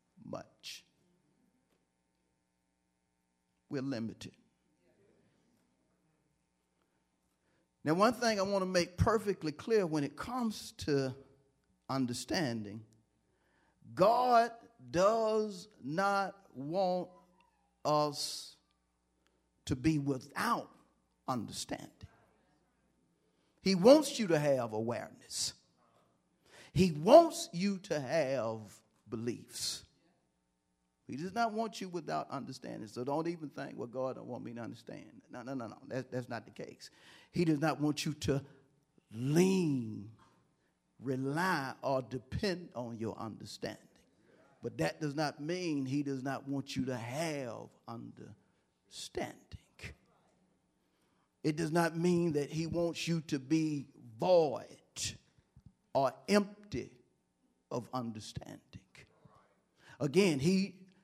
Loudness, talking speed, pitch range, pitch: -34 LUFS, 105 wpm, 110-175 Hz, 140 Hz